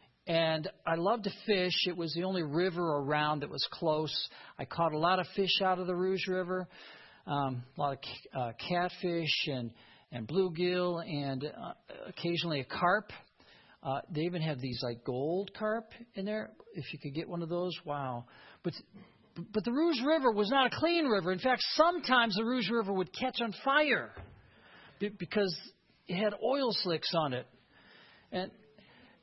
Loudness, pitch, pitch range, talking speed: -33 LUFS, 180 Hz, 155-205 Hz, 180 wpm